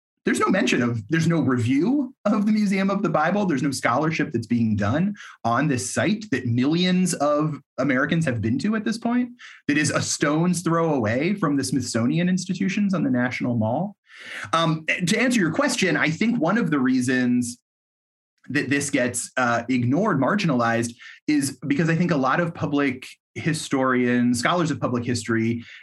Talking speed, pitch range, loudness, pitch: 175 wpm, 125-185 Hz, -22 LUFS, 150 Hz